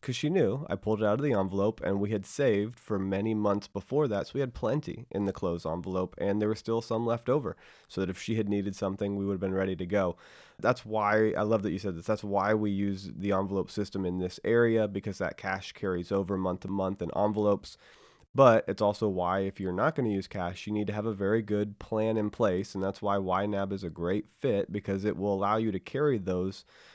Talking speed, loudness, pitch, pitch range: 250 wpm, -30 LUFS, 100 Hz, 95-110 Hz